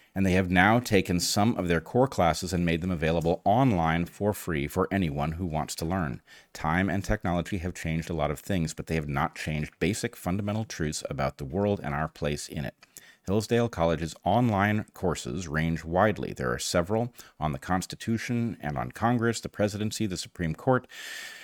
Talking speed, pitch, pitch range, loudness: 190 wpm, 90 Hz, 80-105 Hz, -28 LUFS